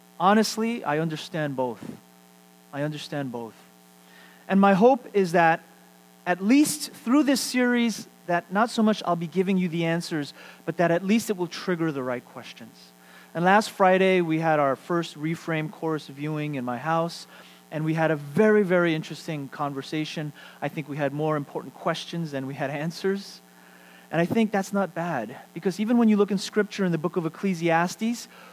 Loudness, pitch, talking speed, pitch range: -25 LUFS, 165 Hz, 185 wpm, 145-195 Hz